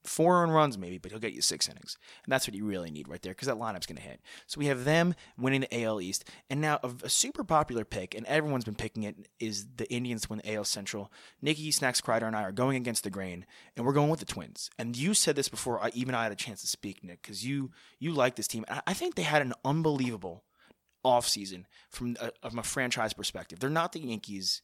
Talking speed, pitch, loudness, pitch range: 255 wpm, 120 Hz, -31 LUFS, 105-140 Hz